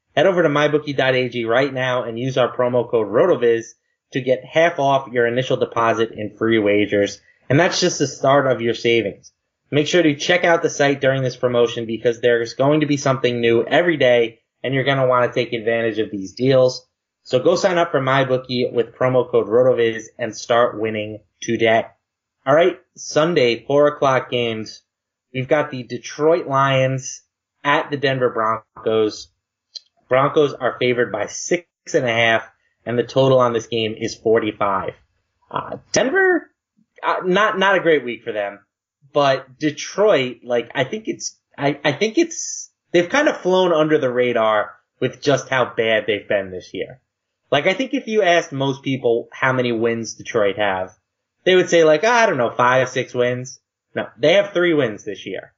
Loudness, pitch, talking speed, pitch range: -18 LUFS, 130 Hz, 185 wpm, 115-150 Hz